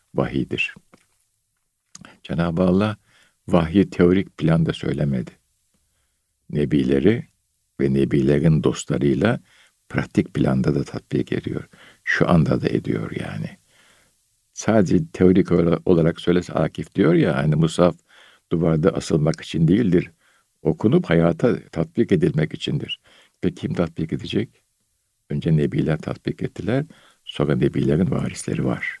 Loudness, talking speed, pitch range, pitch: -21 LUFS, 105 wpm, 75-90 Hz, 85 Hz